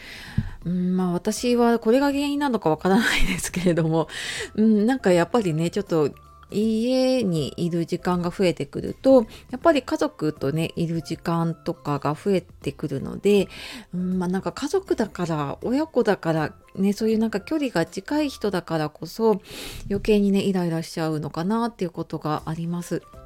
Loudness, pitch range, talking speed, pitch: -24 LUFS, 165-220 Hz, 350 characters per minute, 180 Hz